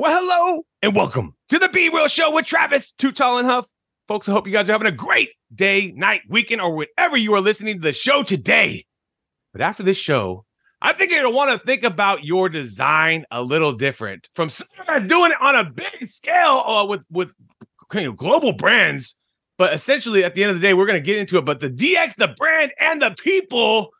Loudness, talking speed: -18 LUFS, 225 wpm